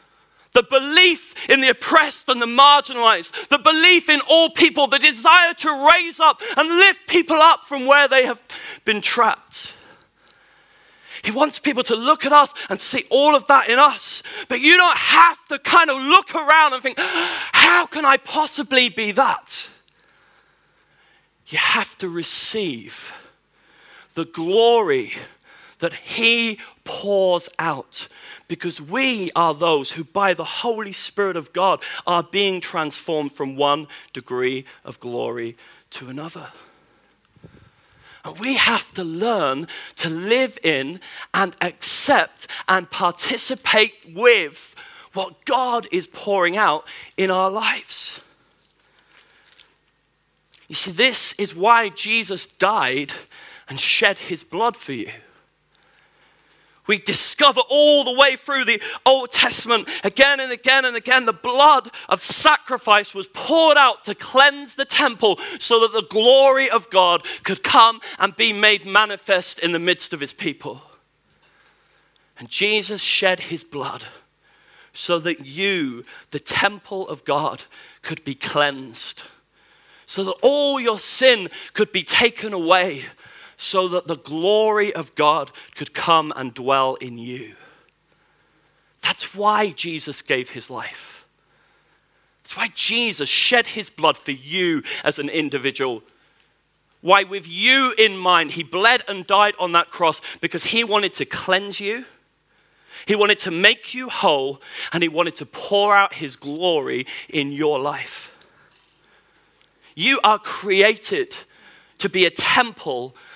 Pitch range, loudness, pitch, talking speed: 175-270 Hz, -17 LUFS, 215 Hz, 140 wpm